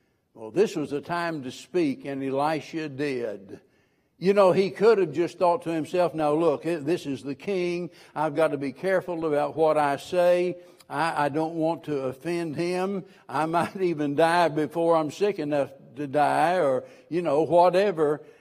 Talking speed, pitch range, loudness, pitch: 180 wpm, 150-175 Hz, -25 LUFS, 165 Hz